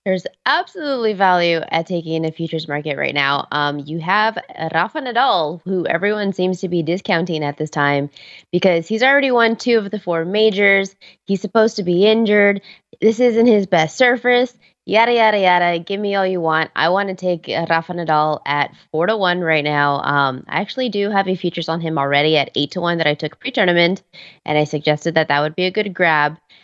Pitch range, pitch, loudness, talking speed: 155-205 Hz, 175 Hz, -17 LUFS, 205 wpm